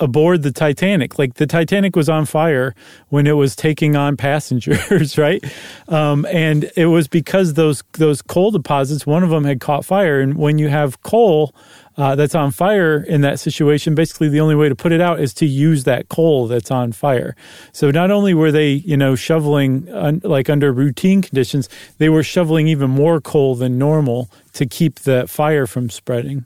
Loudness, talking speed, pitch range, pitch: -15 LUFS, 195 wpm, 140-160 Hz, 150 Hz